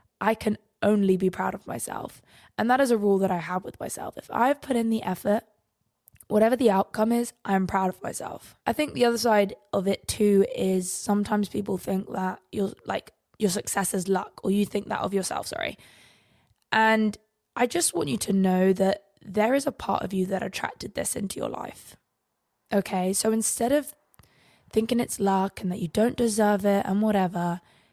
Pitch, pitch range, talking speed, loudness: 205 Hz, 190-220 Hz, 200 wpm, -26 LUFS